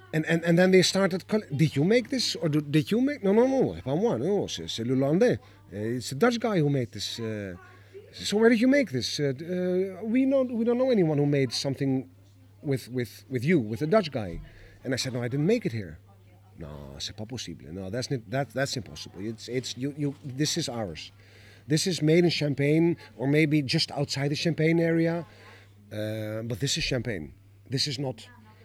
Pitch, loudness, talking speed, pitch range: 135 Hz, -27 LUFS, 200 wpm, 110-165 Hz